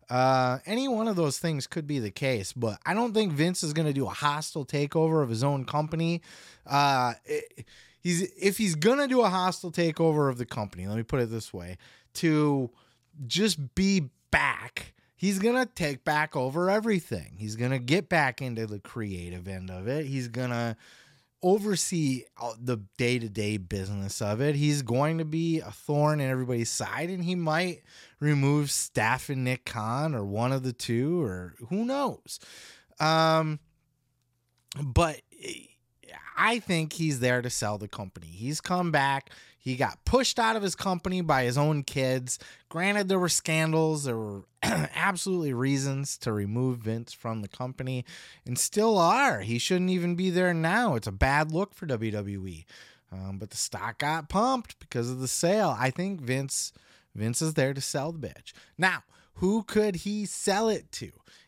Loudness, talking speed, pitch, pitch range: -28 LUFS, 180 wpm, 145 Hz, 120-175 Hz